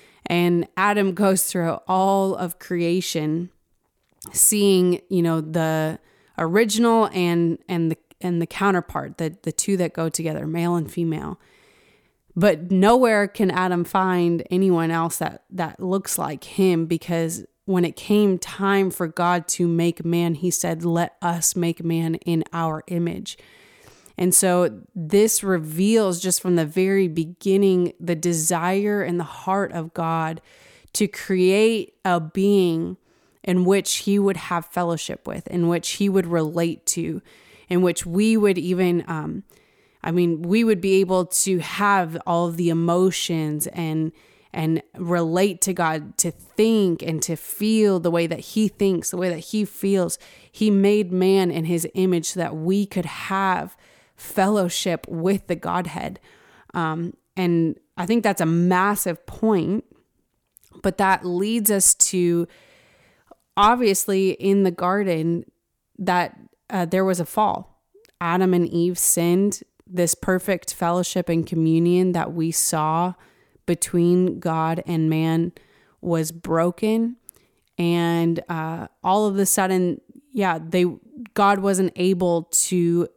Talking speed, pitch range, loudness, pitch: 140 wpm, 170-195 Hz, -21 LUFS, 180 Hz